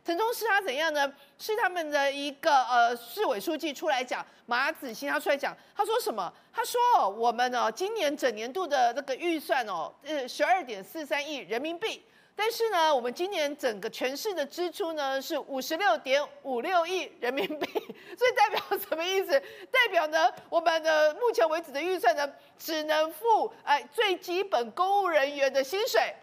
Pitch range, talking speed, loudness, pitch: 280-385 Hz, 275 characters per minute, -28 LUFS, 320 Hz